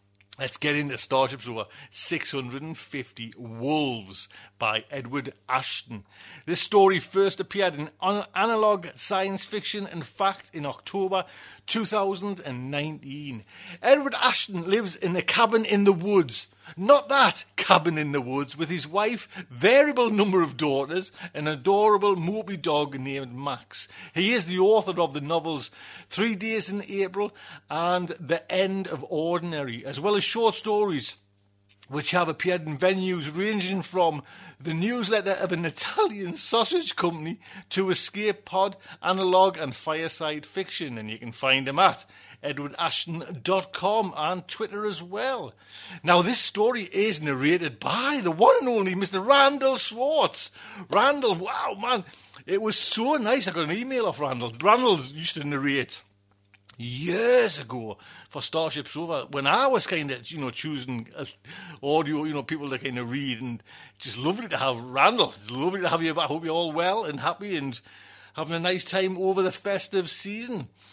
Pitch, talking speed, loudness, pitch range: 175 Hz, 155 wpm, -25 LUFS, 140-200 Hz